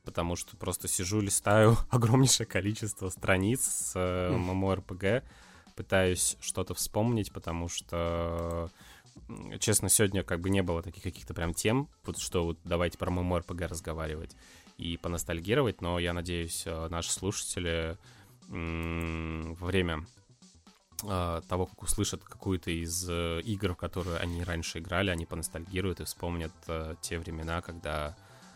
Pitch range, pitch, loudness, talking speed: 85-100 Hz, 90 Hz, -31 LUFS, 135 wpm